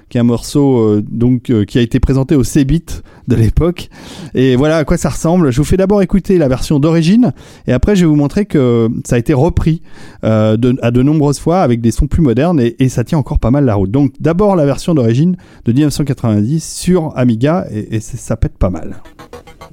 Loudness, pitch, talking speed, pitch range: -13 LUFS, 140 Hz, 230 wpm, 120-160 Hz